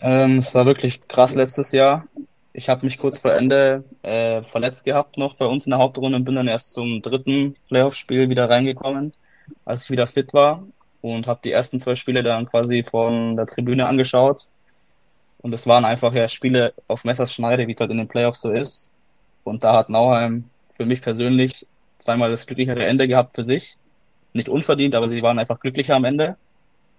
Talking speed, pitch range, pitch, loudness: 190 wpm, 120-135 Hz, 125 Hz, -19 LUFS